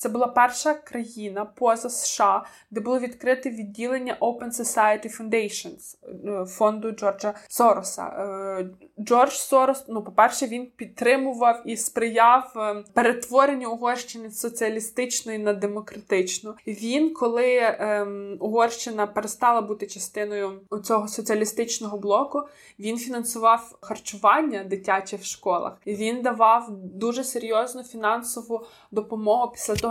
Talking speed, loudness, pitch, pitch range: 110 wpm, -24 LUFS, 225 Hz, 210-245 Hz